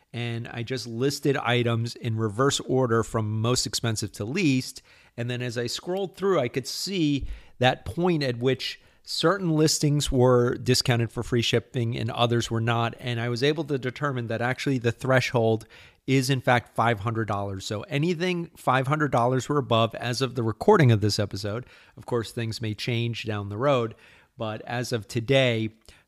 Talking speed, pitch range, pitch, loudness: 175 wpm, 115-135 Hz, 120 Hz, -25 LUFS